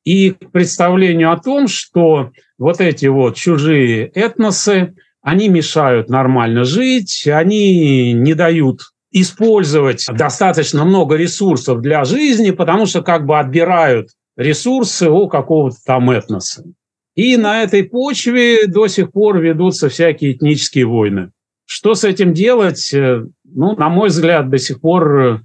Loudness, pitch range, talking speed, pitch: -12 LUFS, 135-195 Hz, 130 wpm, 165 Hz